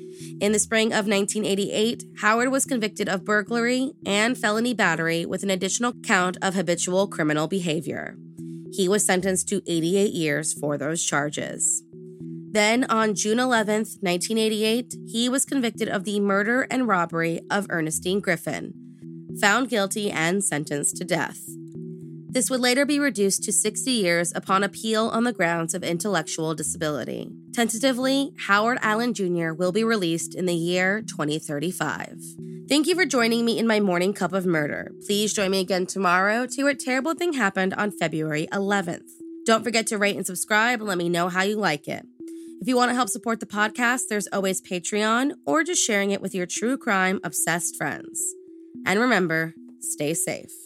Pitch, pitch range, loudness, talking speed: 200 Hz, 170-230 Hz, -23 LUFS, 170 wpm